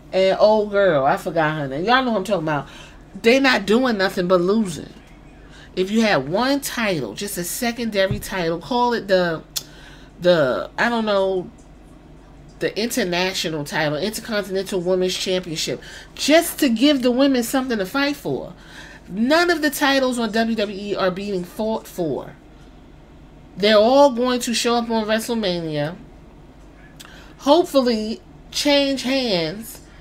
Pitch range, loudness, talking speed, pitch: 185-245 Hz, -20 LUFS, 145 wpm, 205 Hz